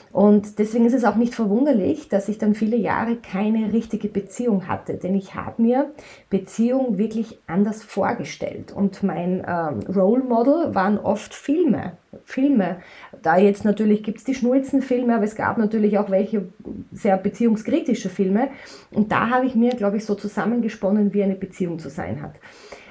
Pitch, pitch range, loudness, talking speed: 210 Hz, 195-235 Hz, -21 LUFS, 170 wpm